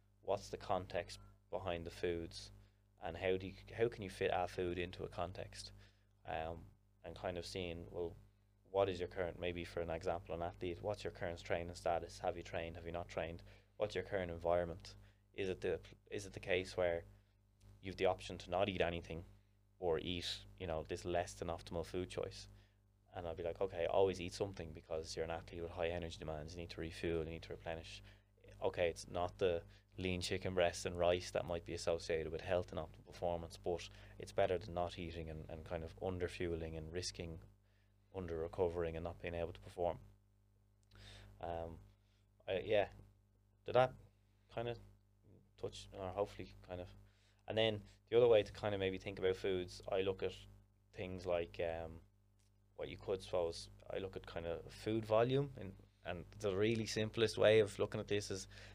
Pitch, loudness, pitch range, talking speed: 95 Hz, -42 LUFS, 85-100 Hz, 195 wpm